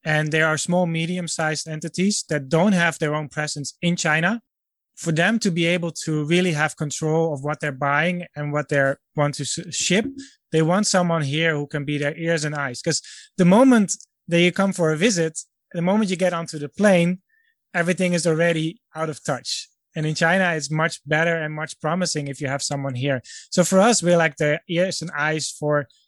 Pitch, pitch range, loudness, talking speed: 165 Hz, 150-180 Hz, -21 LUFS, 210 wpm